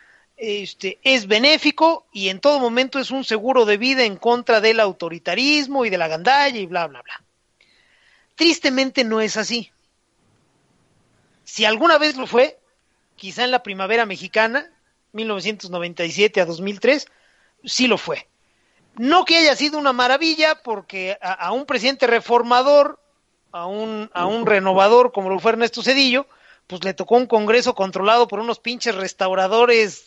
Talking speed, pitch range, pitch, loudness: 150 wpm, 195-265 Hz, 230 Hz, -18 LUFS